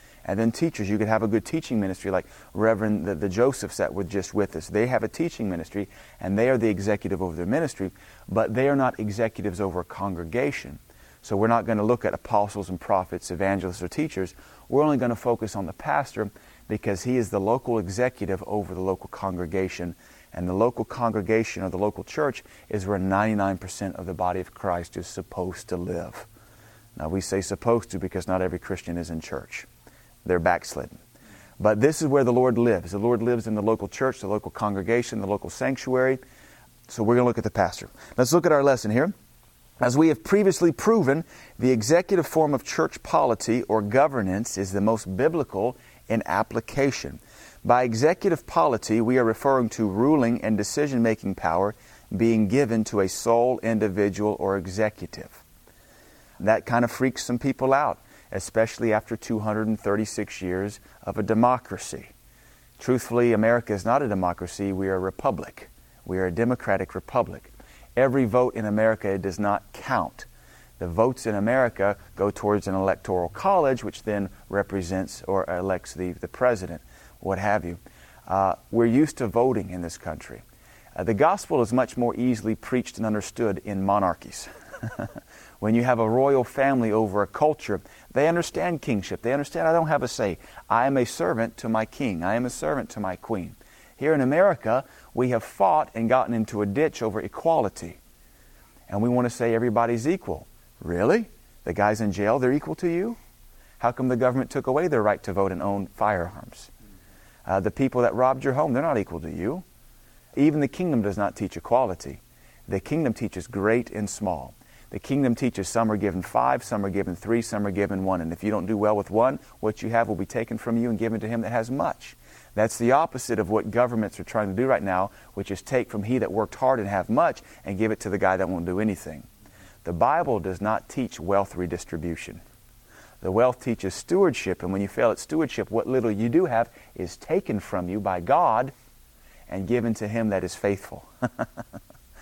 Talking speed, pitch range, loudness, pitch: 195 wpm, 95-120 Hz, -25 LUFS, 110 Hz